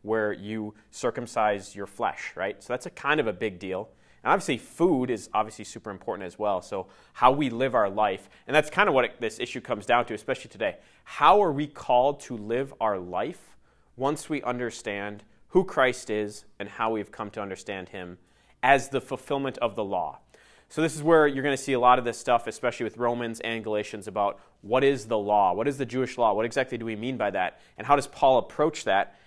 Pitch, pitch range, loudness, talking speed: 115 Hz, 105-130 Hz, -26 LUFS, 225 wpm